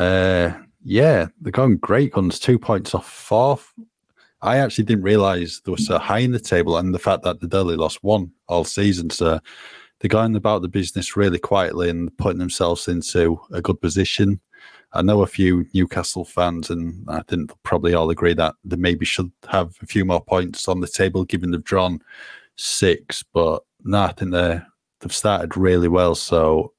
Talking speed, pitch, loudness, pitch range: 190 wpm, 90 Hz, -20 LUFS, 85-100 Hz